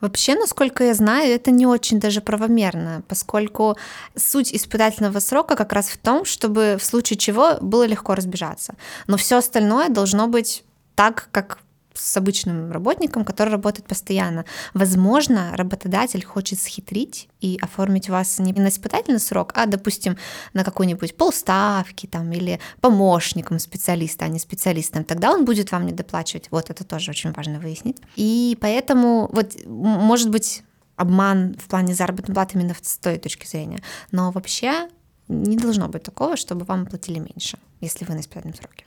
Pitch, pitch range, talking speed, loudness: 200 Hz, 180-225 Hz, 160 wpm, -20 LUFS